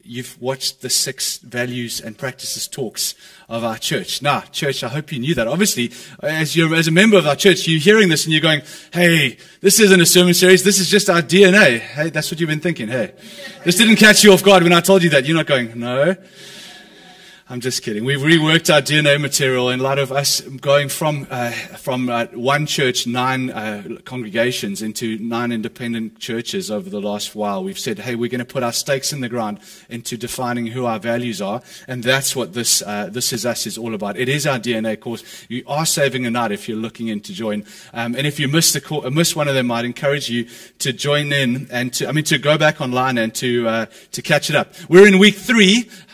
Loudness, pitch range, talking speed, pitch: -16 LUFS, 120-185 Hz, 230 wpm, 140 Hz